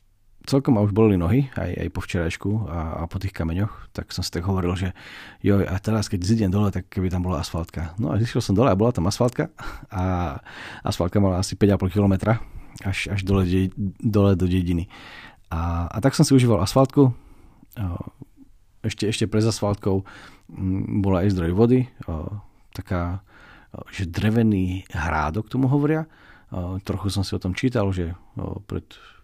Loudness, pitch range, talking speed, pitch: -23 LUFS, 90-110 Hz, 175 wpm, 100 Hz